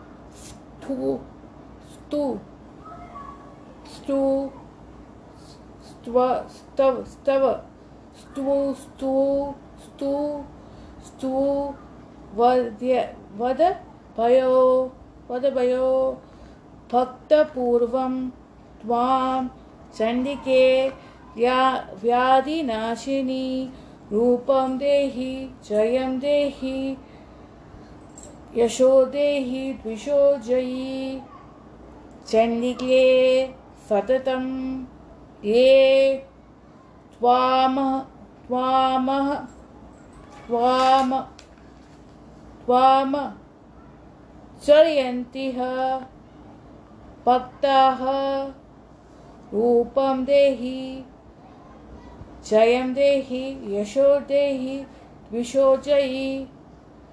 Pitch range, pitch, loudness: 250-275 Hz, 260 Hz, -22 LUFS